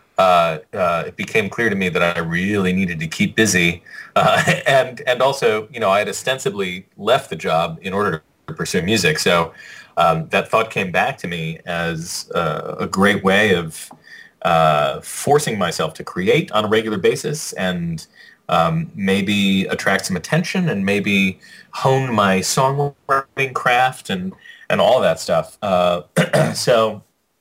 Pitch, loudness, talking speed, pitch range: 100 Hz, -18 LUFS, 160 wpm, 90-135 Hz